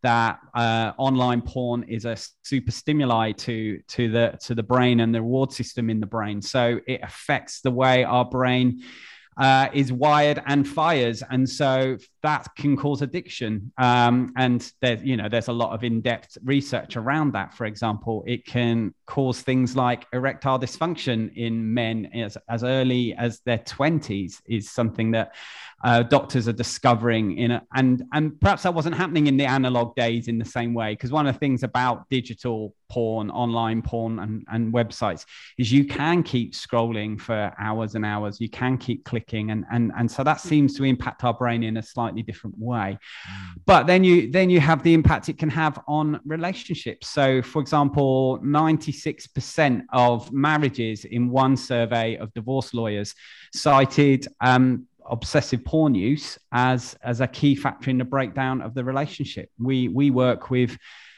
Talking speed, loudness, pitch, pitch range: 175 wpm, -23 LUFS, 125 Hz, 115-135 Hz